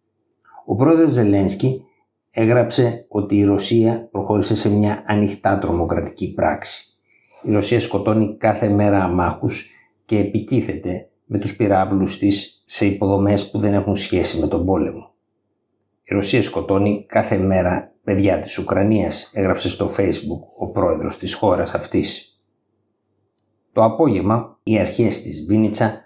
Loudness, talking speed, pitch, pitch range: -19 LUFS, 130 wpm, 105 Hz, 100-110 Hz